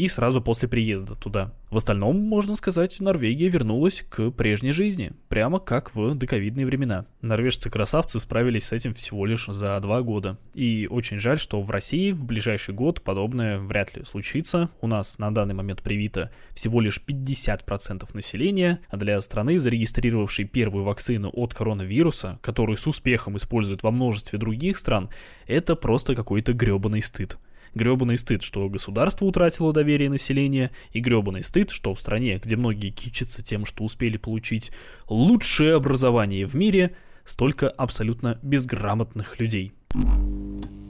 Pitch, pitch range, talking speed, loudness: 115 Hz, 105-135 Hz, 145 wpm, -24 LUFS